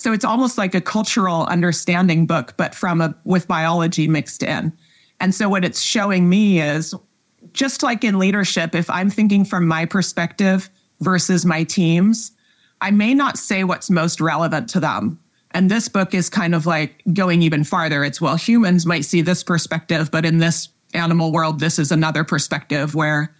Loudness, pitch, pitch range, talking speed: -18 LUFS, 175 Hz, 160-195 Hz, 180 wpm